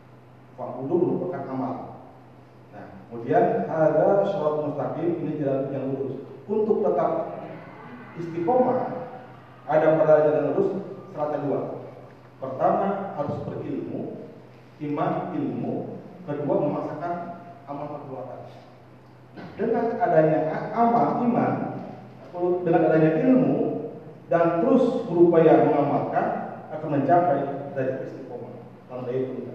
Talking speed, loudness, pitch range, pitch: 90 wpm, -24 LUFS, 145-195 Hz, 160 Hz